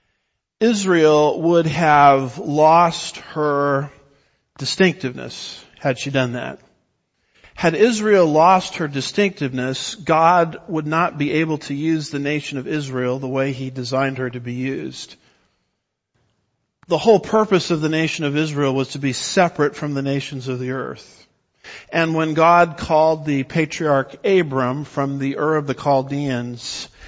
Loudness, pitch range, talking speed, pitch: -19 LUFS, 135-165 Hz, 145 wpm, 145 Hz